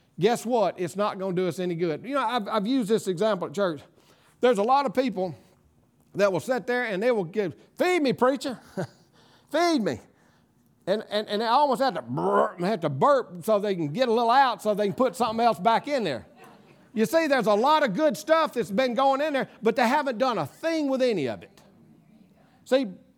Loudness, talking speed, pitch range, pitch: -25 LUFS, 225 wpm, 200-265 Hz, 230 Hz